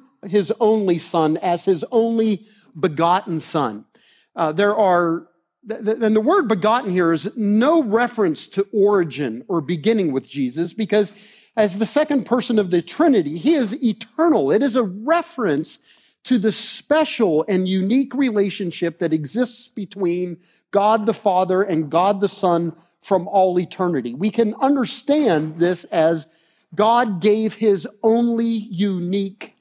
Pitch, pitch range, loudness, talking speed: 205 Hz, 175-225 Hz, -19 LUFS, 140 wpm